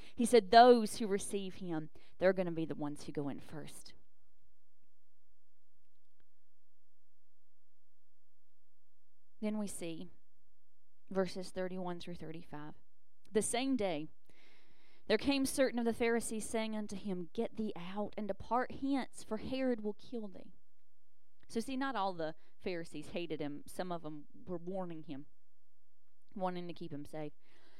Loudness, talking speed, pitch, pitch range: -36 LUFS, 140 wpm, 180 Hz, 145-220 Hz